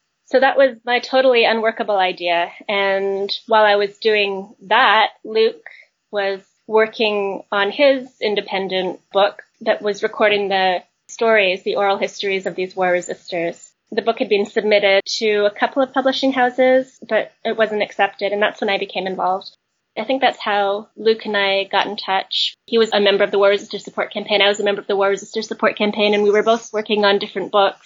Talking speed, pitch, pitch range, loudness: 195 wpm, 205 Hz, 195-225 Hz, -18 LUFS